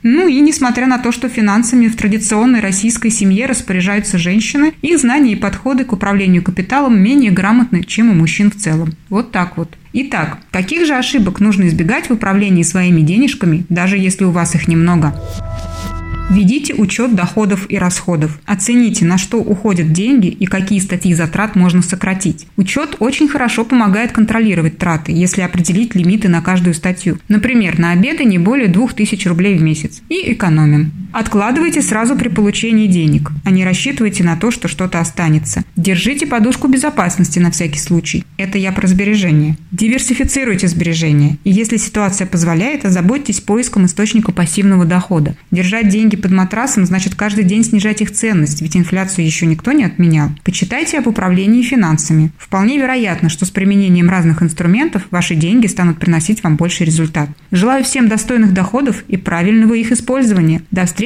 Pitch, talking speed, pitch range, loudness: 195 Hz, 160 wpm, 175-225 Hz, -13 LUFS